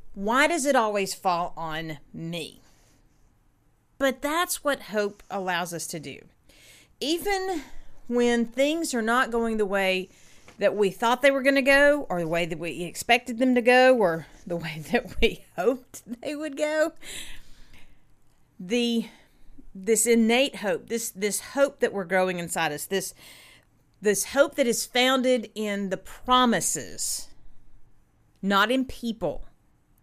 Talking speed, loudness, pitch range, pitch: 145 wpm, -25 LUFS, 190-265 Hz, 230 Hz